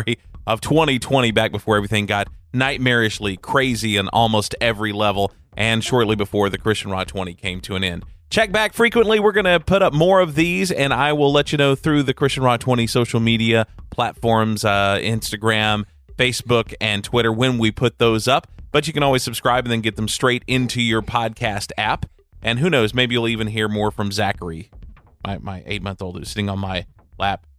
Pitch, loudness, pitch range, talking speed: 115 Hz, -19 LUFS, 100-125 Hz, 195 wpm